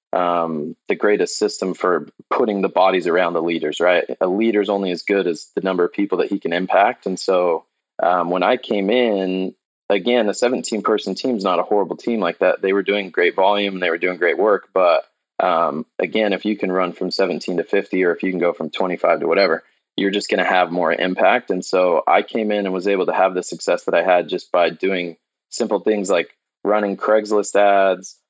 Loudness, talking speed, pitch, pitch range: -19 LUFS, 225 wpm, 95 Hz, 90-105 Hz